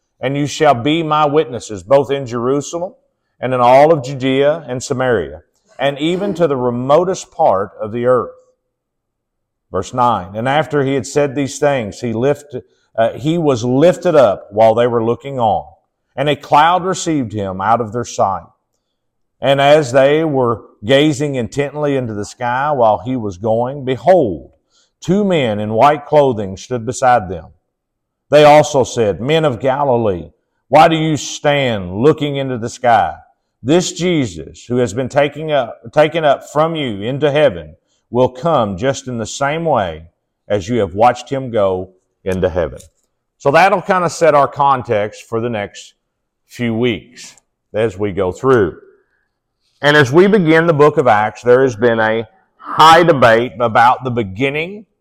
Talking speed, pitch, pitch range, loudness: 165 wpm, 135 Hz, 115-150 Hz, -14 LUFS